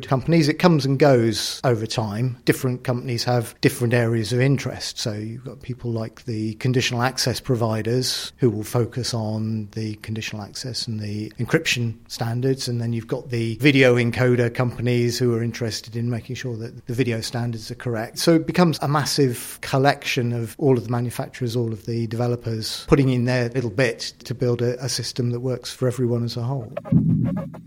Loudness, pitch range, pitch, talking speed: -22 LUFS, 115-130 Hz, 120 Hz, 185 wpm